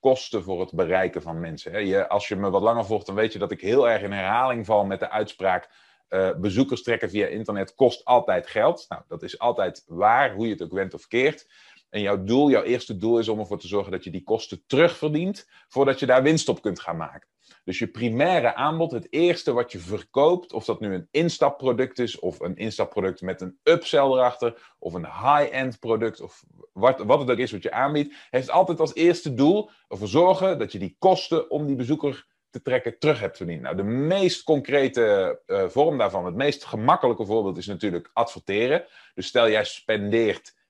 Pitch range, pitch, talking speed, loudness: 105-155 Hz, 125 Hz, 210 wpm, -23 LUFS